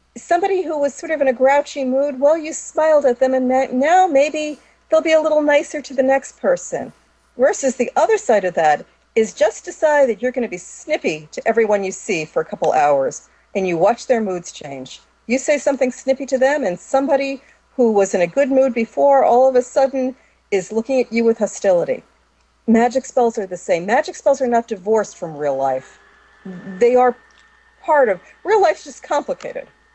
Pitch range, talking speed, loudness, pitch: 225-295 Hz, 200 wpm, -18 LUFS, 260 Hz